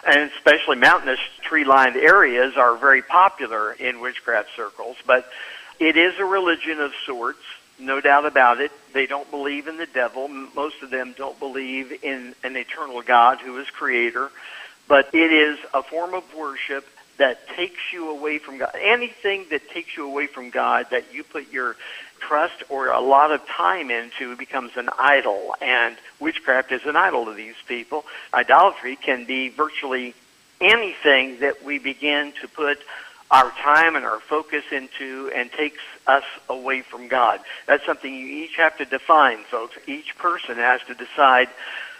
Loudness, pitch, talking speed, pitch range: -20 LUFS, 140 Hz, 170 wpm, 130-155 Hz